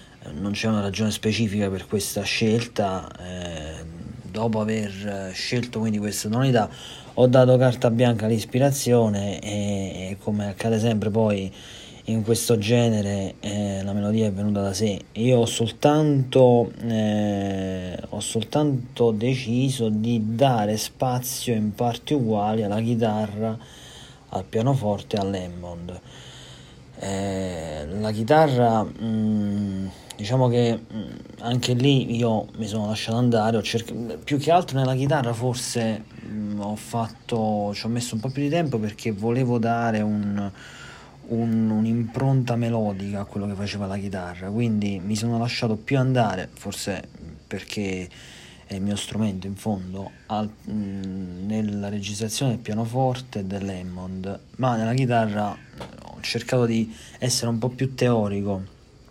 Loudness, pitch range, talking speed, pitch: -24 LUFS, 100-120 Hz, 130 wpm, 110 Hz